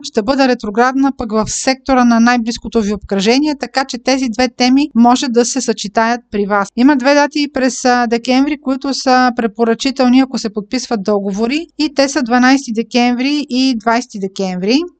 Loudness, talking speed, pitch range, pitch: -14 LUFS, 165 wpm, 230-265 Hz, 250 Hz